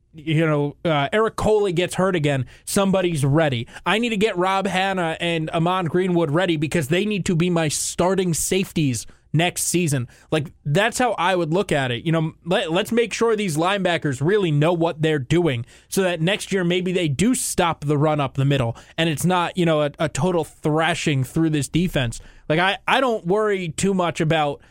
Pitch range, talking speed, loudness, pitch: 155-185 Hz, 205 wpm, -21 LUFS, 170 Hz